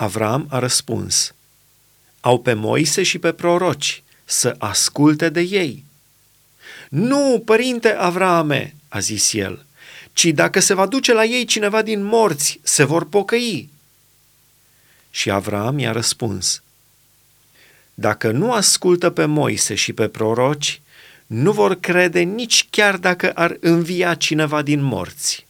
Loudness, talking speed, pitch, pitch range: -17 LUFS, 130 wpm, 150 Hz, 125-185 Hz